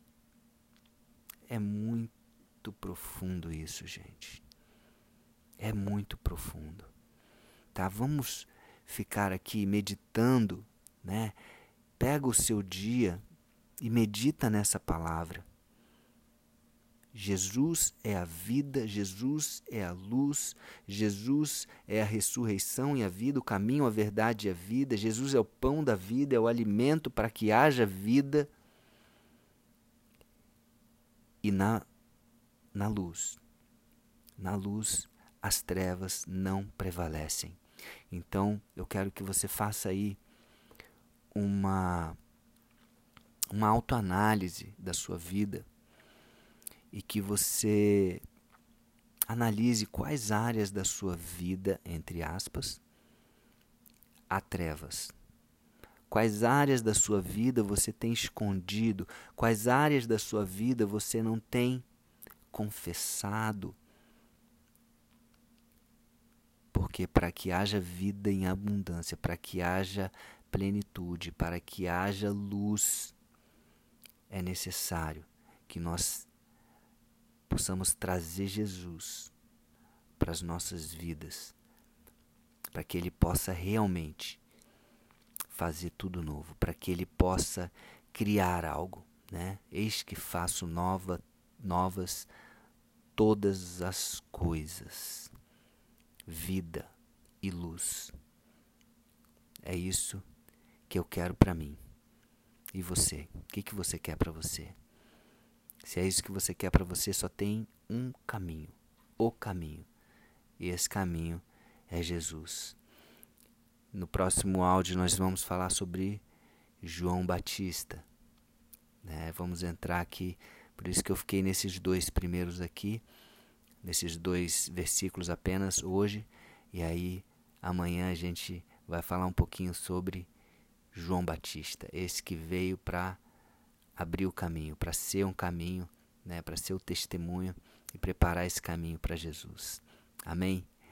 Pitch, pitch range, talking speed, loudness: 95 Hz, 90-110 Hz, 110 wpm, -33 LUFS